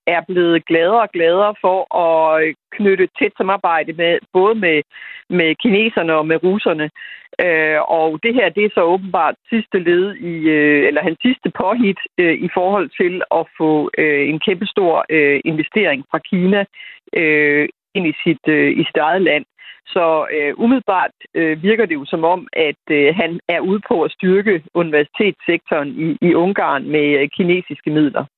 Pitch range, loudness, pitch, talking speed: 155-205 Hz, -16 LUFS, 175 Hz, 165 wpm